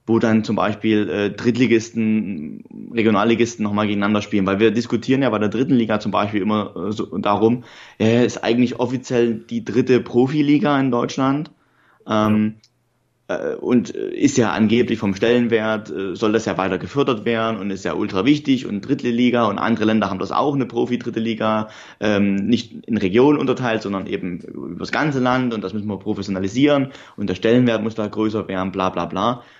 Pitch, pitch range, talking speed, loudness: 115 Hz, 105-125 Hz, 185 wpm, -19 LUFS